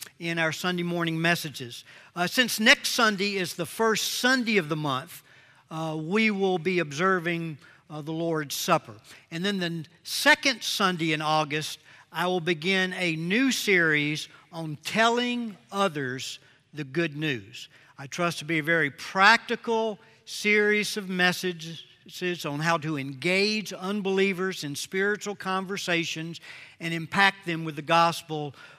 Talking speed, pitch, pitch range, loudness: 140 wpm, 170 Hz, 155-195 Hz, -25 LUFS